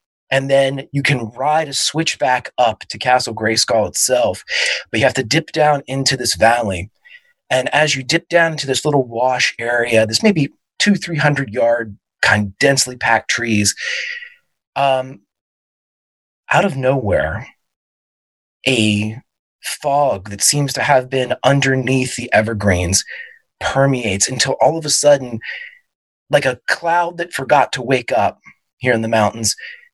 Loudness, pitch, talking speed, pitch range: -16 LUFS, 130 Hz, 150 wpm, 115-150 Hz